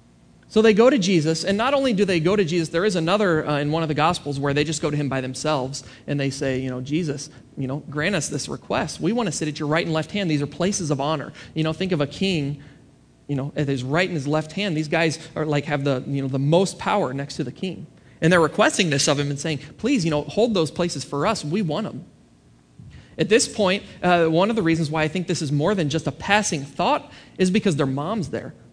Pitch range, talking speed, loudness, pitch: 145-180 Hz, 270 wpm, -22 LUFS, 155 Hz